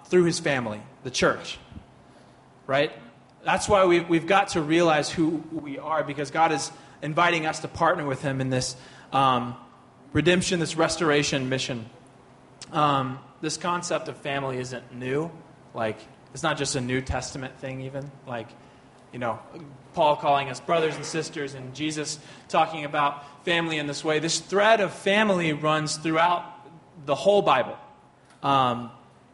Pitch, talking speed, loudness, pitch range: 150 Hz, 155 wpm, -25 LUFS, 135-165 Hz